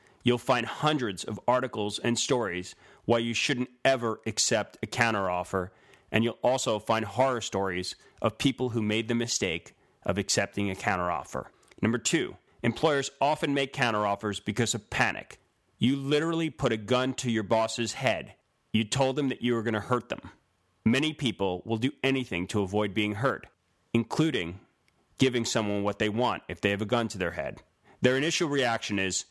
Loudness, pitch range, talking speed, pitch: -28 LUFS, 105-130 Hz, 175 wpm, 115 Hz